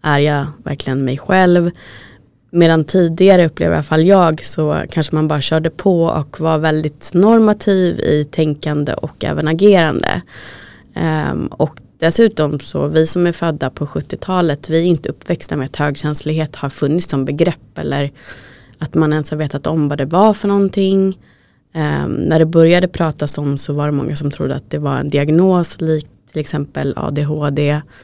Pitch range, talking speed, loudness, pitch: 145-170 Hz, 175 wpm, -15 LUFS, 155 Hz